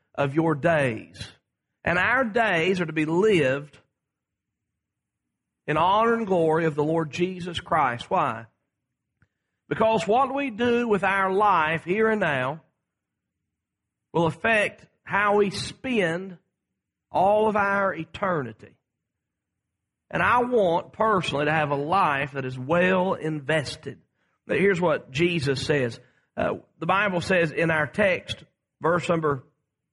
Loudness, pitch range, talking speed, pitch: -24 LUFS, 145-200 Hz, 130 wpm, 170 Hz